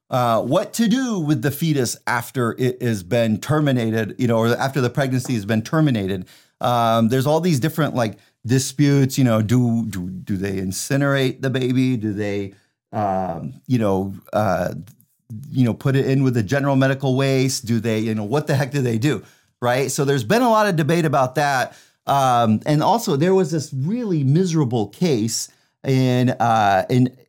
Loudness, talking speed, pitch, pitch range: -20 LUFS, 185 wpm, 130 Hz, 115-145 Hz